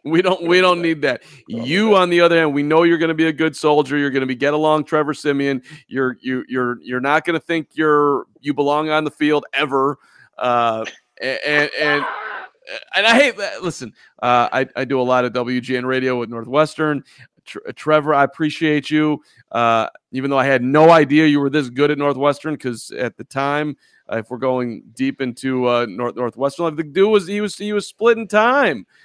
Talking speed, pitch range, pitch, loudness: 210 wpm, 130-155 Hz, 145 Hz, -18 LUFS